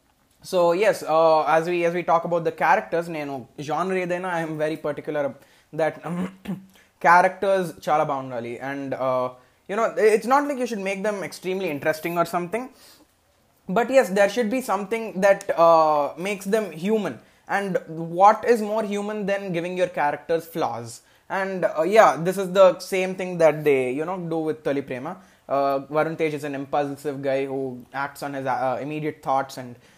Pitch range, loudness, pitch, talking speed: 145-190 Hz, -23 LUFS, 165 Hz, 180 wpm